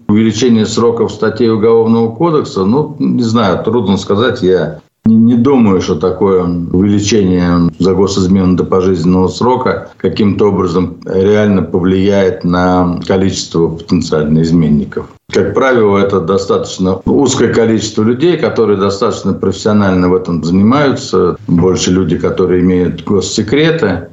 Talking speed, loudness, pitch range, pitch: 120 wpm, -11 LUFS, 90-105 Hz, 95 Hz